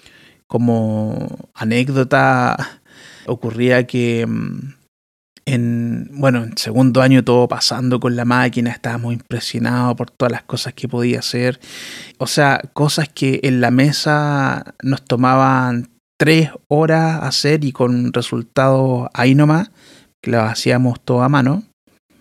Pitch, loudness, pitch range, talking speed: 125 Hz, -16 LUFS, 120-135 Hz, 125 wpm